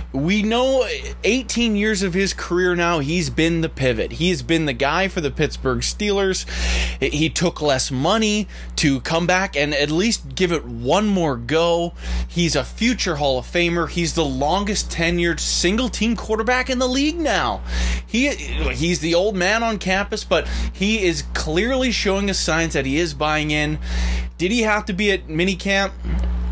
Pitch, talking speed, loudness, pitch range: 170 Hz, 180 wpm, -20 LUFS, 145-200 Hz